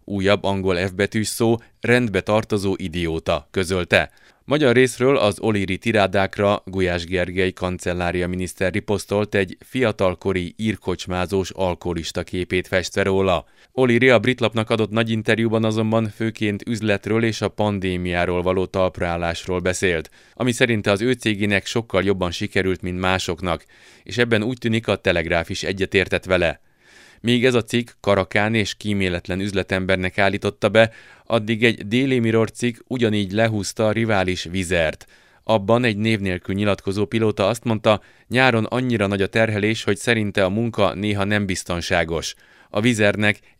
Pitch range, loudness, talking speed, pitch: 95-115 Hz, -21 LUFS, 140 wpm, 100 Hz